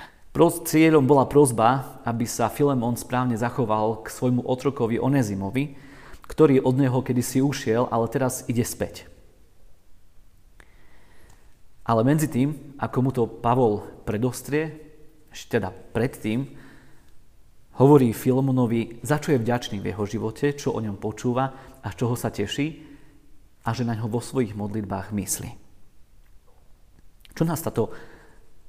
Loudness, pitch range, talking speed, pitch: -24 LUFS, 105-135 Hz, 125 wpm, 120 Hz